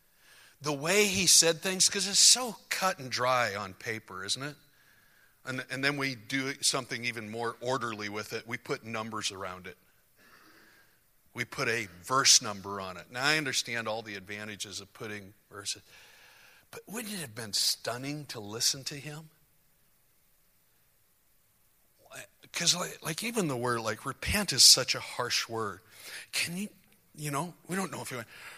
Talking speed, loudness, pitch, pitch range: 170 wpm, -28 LUFS, 130 Hz, 110-155 Hz